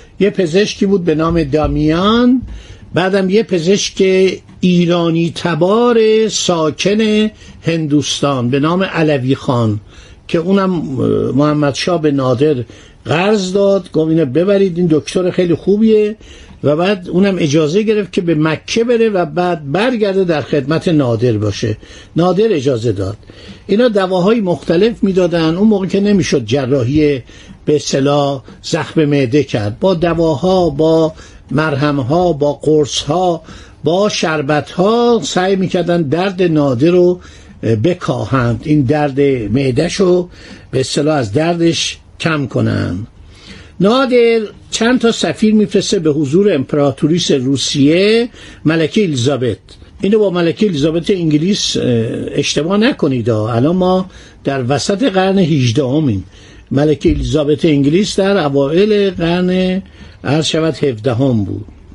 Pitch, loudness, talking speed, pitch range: 160 Hz, -13 LUFS, 120 wpm, 140-190 Hz